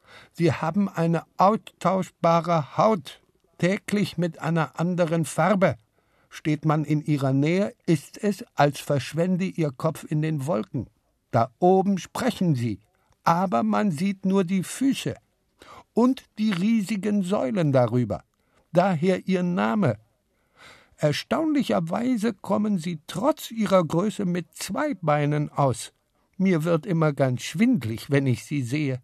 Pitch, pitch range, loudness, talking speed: 170 Hz, 150-200 Hz, -24 LUFS, 125 wpm